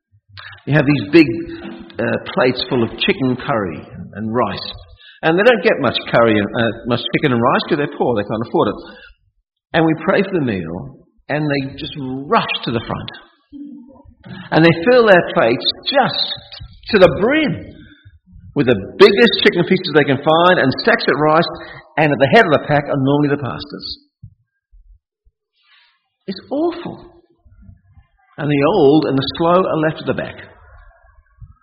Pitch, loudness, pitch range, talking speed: 150 Hz, -15 LUFS, 130-190 Hz, 170 wpm